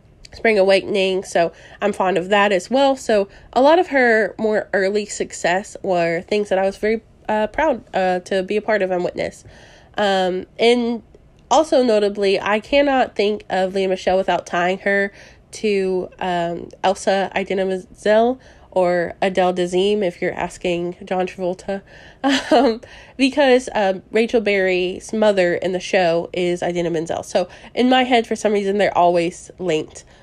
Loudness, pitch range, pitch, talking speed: -19 LUFS, 180-220 Hz, 195 Hz, 160 wpm